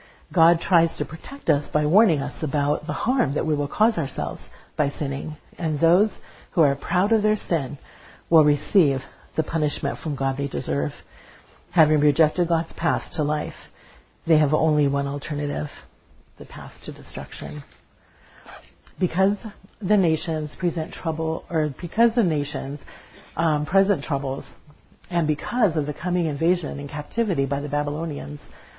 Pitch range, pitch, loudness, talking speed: 140-175 Hz, 155 Hz, -23 LUFS, 150 wpm